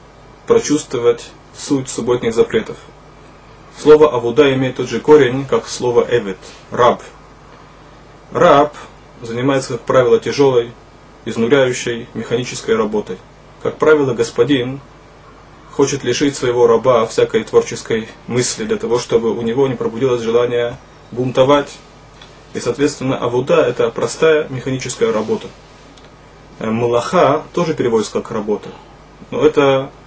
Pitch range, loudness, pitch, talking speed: 120-150 Hz, -15 LUFS, 140 Hz, 110 wpm